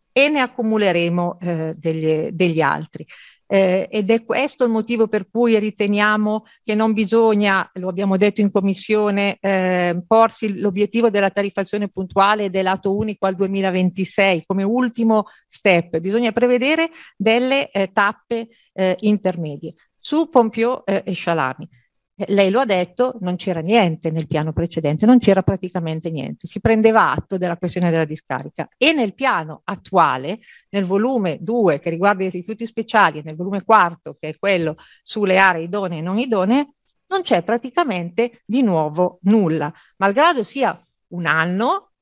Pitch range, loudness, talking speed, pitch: 180-225 Hz, -19 LUFS, 150 wpm, 200 Hz